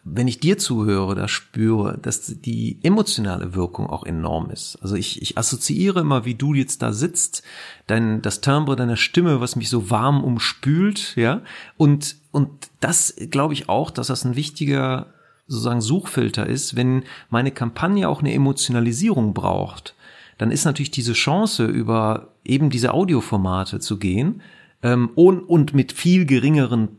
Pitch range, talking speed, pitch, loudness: 115-150 Hz, 160 wpm, 130 Hz, -20 LUFS